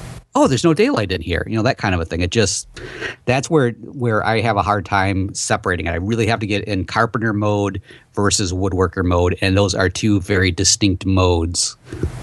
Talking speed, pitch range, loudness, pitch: 210 wpm, 95-115 Hz, -18 LUFS, 100 Hz